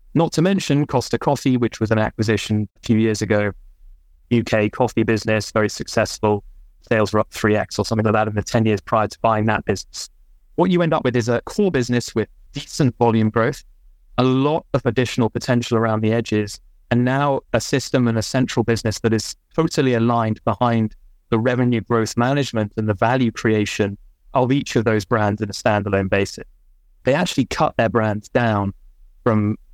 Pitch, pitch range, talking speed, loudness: 115 Hz, 105-125 Hz, 190 wpm, -20 LUFS